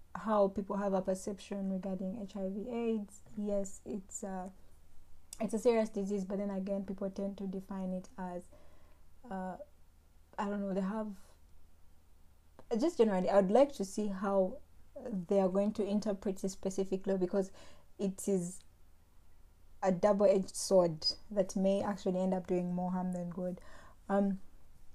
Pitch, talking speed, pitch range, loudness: 195 Hz, 150 wpm, 180-200 Hz, -35 LUFS